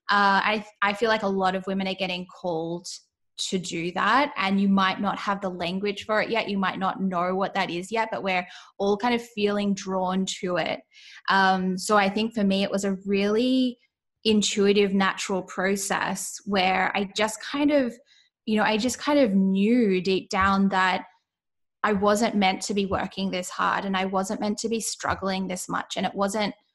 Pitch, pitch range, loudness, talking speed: 195 Hz, 190-215 Hz, -25 LUFS, 200 wpm